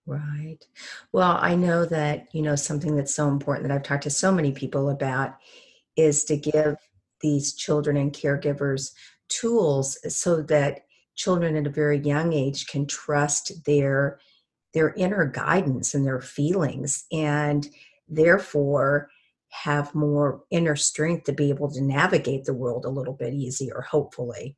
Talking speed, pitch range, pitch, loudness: 150 wpm, 140-155 Hz, 145 Hz, -24 LUFS